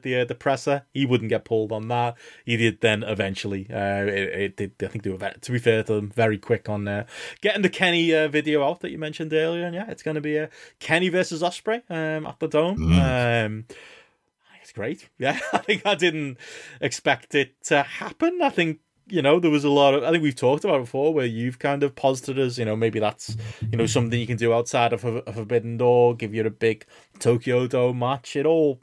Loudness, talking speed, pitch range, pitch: -23 LUFS, 235 wpm, 115-155 Hz, 125 Hz